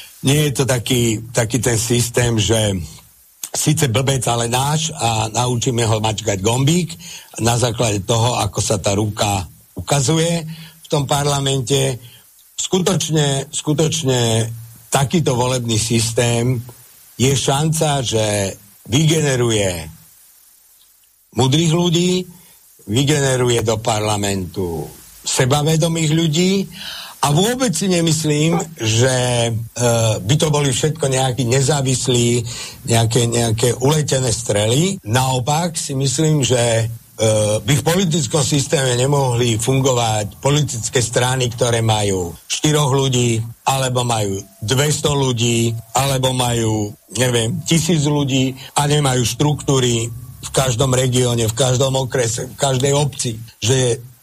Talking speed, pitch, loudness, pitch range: 110 wpm, 130 Hz, -17 LUFS, 115-145 Hz